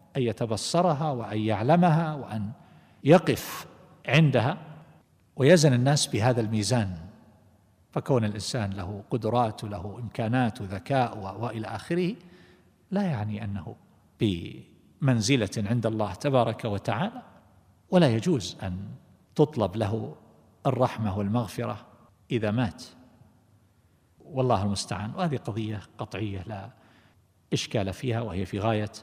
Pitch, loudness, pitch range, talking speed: 115 Hz, -27 LUFS, 105-130 Hz, 100 wpm